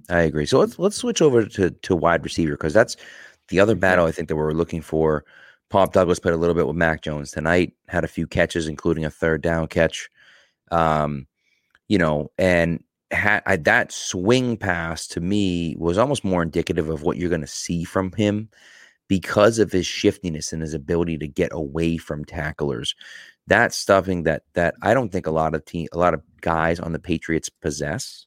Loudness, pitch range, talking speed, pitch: -21 LUFS, 80-95 Hz, 200 wpm, 85 Hz